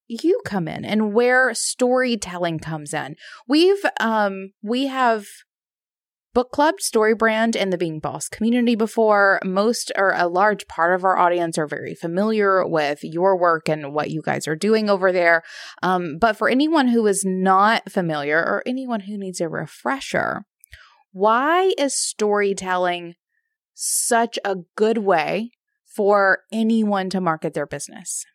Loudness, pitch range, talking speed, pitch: -20 LUFS, 180-235 Hz, 150 wpm, 205 Hz